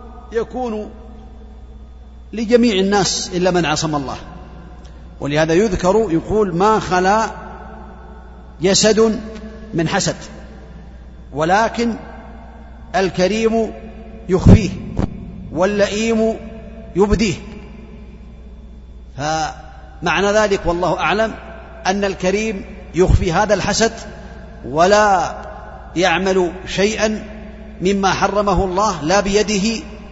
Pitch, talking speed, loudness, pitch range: 200 Hz, 75 wpm, -17 LUFS, 175-215 Hz